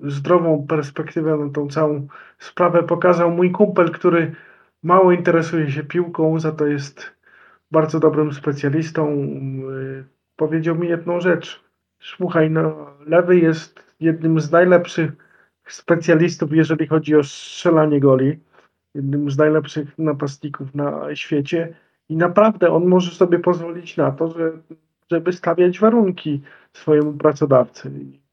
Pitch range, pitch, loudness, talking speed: 150-170 Hz, 160 Hz, -18 LUFS, 125 wpm